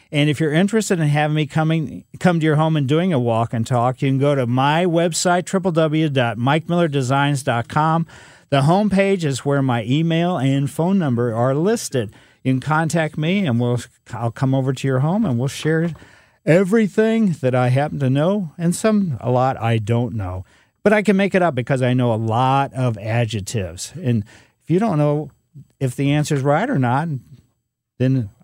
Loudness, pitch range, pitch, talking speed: -19 LUFS, 125-165 Hz, 140 Hz, 190 wpm